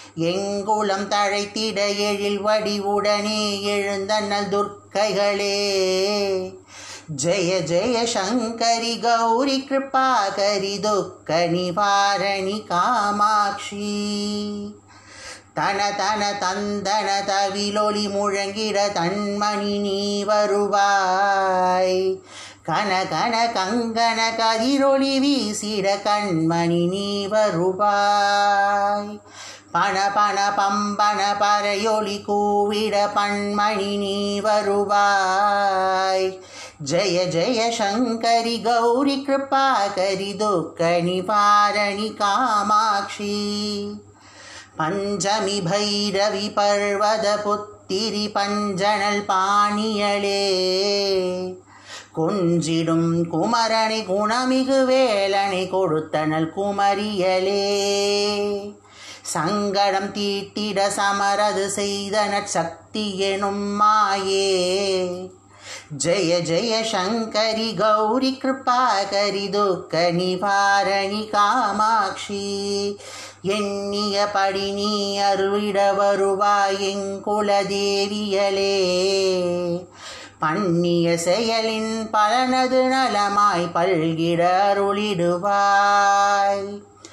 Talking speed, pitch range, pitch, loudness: 55 wpm, 195-210 Hz, 205 Hz, -20 LUFS